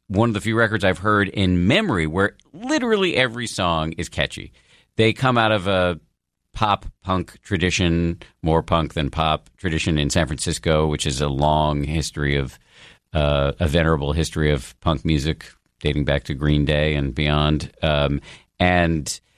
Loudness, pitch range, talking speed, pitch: -21 LUFS, 75-95 Hz, 165 wpm, 80 Hz